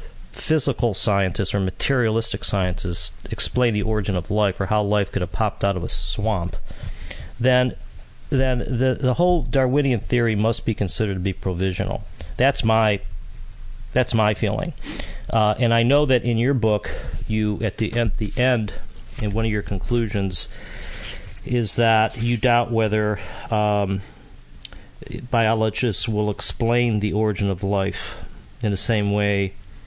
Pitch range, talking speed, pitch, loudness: 100-120 Hz, 150 wpm, 110 Hz, -22 LUFS